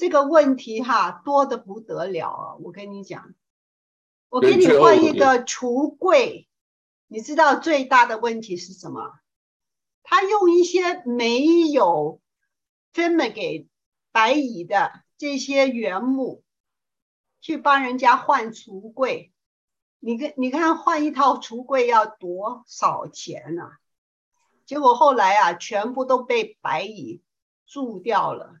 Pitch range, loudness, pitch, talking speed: 225-315 Hz, -20 LUFS, 265 Hz, 180 characters per minute